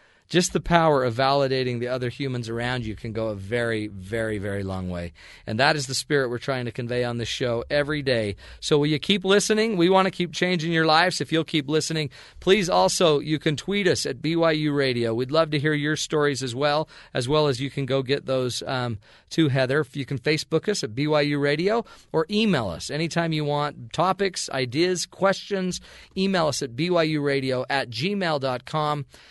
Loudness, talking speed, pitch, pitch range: -24 LUFS, 205 wpm, 145 Hz, 125-165 Hz